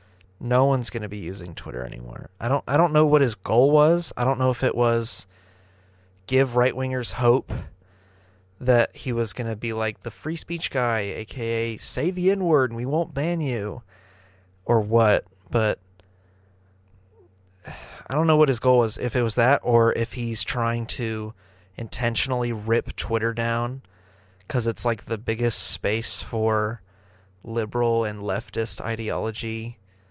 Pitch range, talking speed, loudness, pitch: 95-125 Hz, 155 wpm, -24 LUFS, 115 Hz